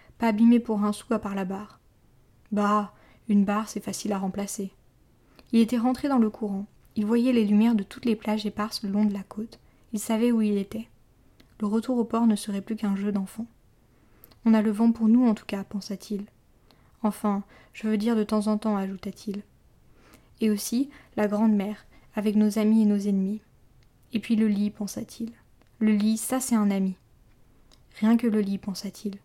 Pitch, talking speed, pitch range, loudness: 210 Hz, 200 wpm, 200-225 Hz, -26 LUFS